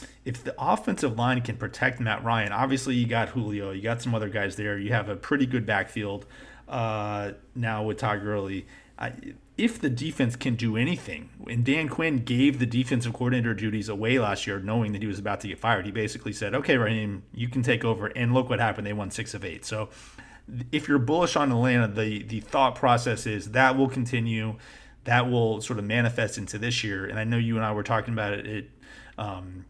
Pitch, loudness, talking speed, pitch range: 115 Hz, -27 LUFS, 210 wpm, 105-125 Hz